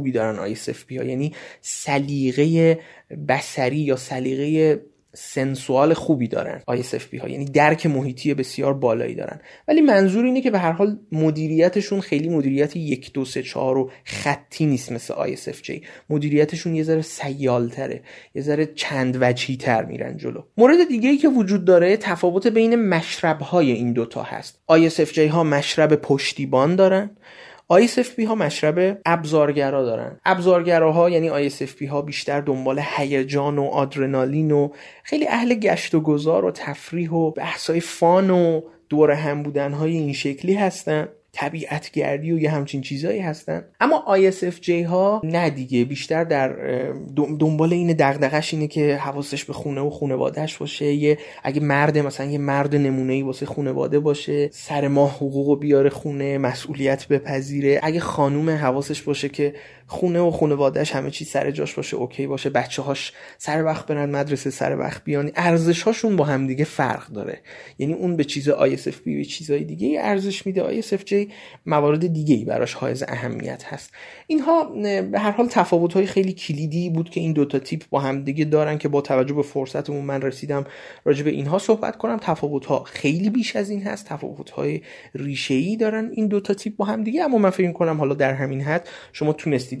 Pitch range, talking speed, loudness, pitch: 140-175 Hz, 170 wpm, -21 LUFS, 150 Hz